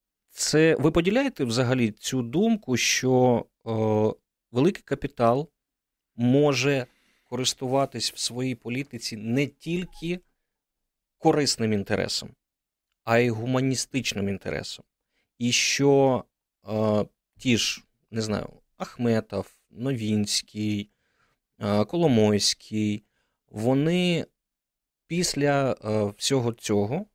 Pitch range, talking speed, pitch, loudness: 110-140 Hz, 85 wpm, 120 Hz, -25 LUFS